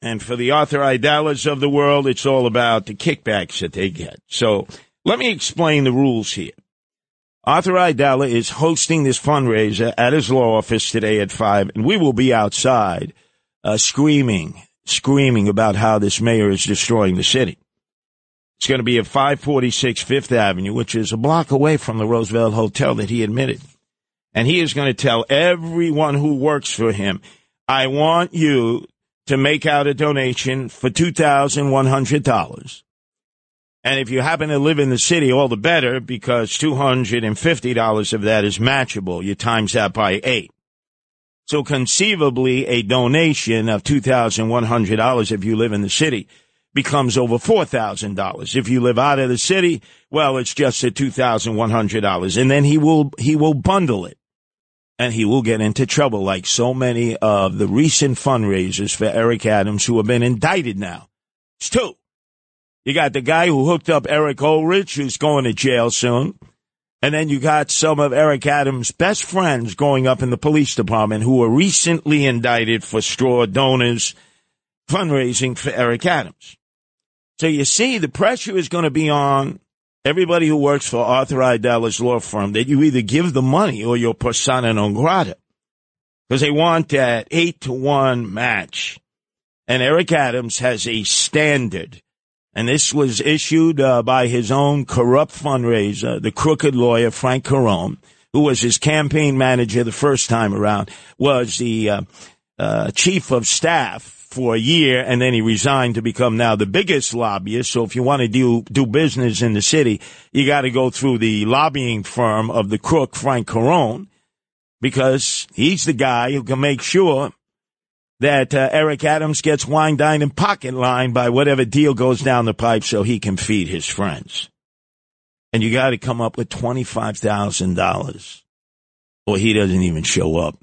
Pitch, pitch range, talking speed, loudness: 130 Hz, 115-145 Hz, 180 wpm, -17 LUFS